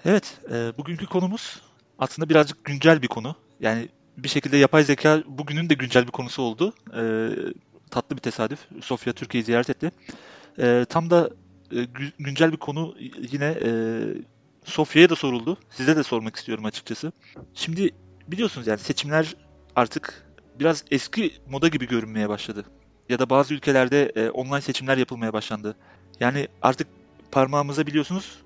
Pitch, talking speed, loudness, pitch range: 135 Hz, 150 wpm, -24 LUFS, 115-155 Hz